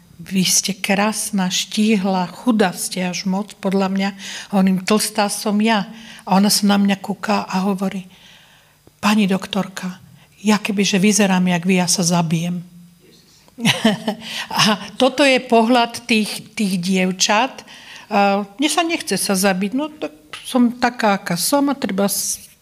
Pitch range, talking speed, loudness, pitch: 185-220 Hz, 145 wpm, -18 LUFS, 200 Hz